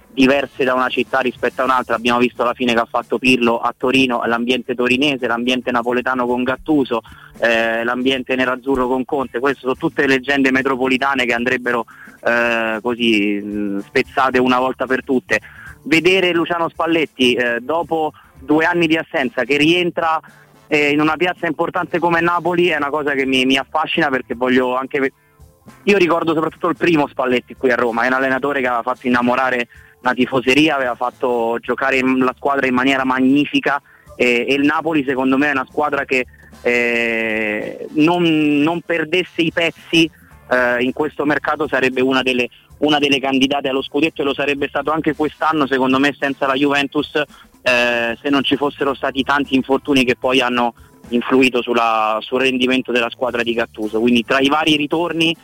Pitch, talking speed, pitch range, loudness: 130 Hz, 170 wpm, 125-150 Hz, -17 LUFS